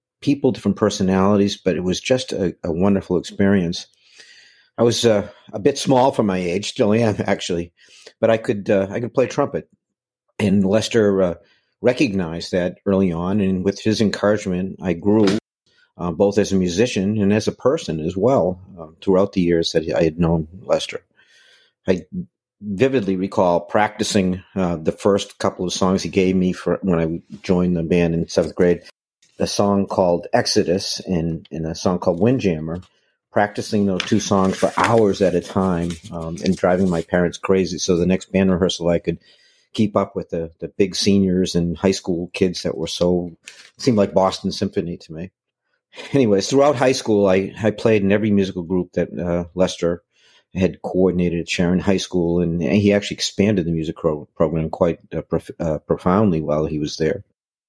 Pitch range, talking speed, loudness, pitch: 85-100 Hz, 180 wpm, -19 LUFS, 95 Hz